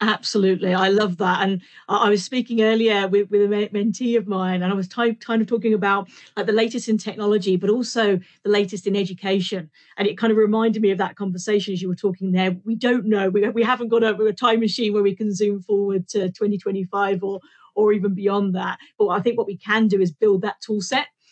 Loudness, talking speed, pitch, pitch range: -21 LUFS, 235 wpm, 205 Hz, 195-220 Hz